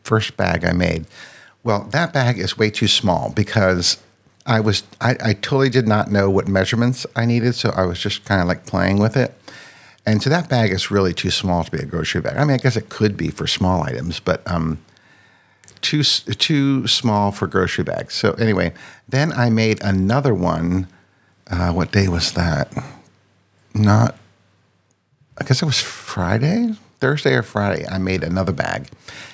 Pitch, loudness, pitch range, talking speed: 105 Hz, -19 LUFS, 95-120 Hz, 180 wpm